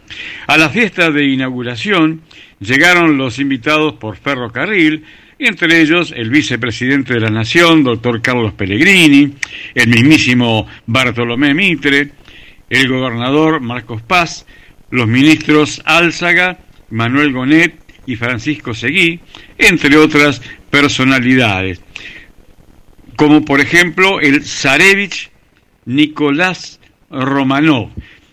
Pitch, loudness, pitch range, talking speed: 140 Hz, -11 LUFS, 120-155 Hz, 100 wpm